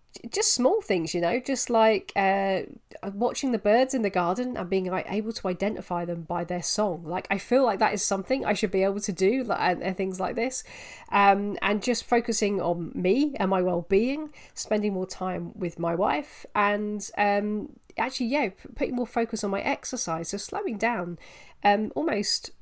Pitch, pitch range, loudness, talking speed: 205 Hz, 190-235 Hz, -26 LUFS, 195 wpm